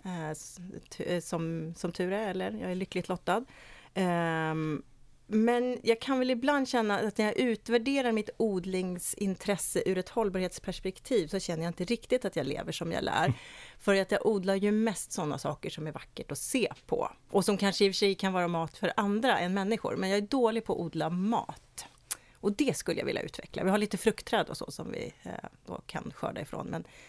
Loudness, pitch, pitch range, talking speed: -31 LUFS, 195 Hz, 175-220 Hz, 200 wpm